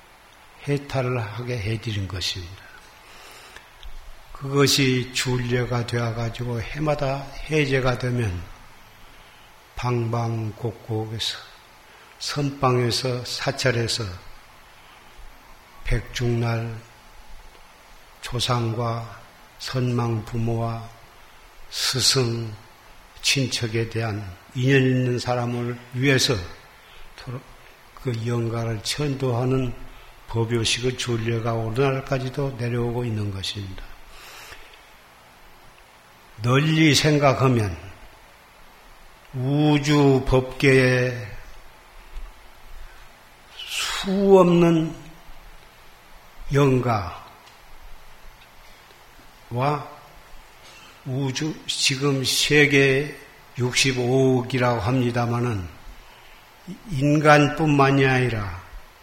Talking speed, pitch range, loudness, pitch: 145 characters per minute, 115-135 Hz, -22 LUFS, 125 Hz